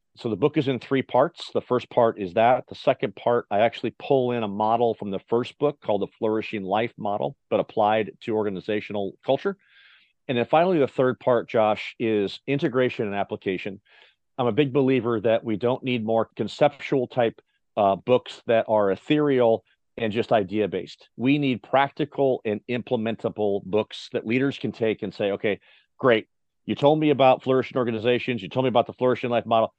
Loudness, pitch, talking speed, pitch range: -24 LUFS, 120 Hz, 190 wpm, 110-130 Hz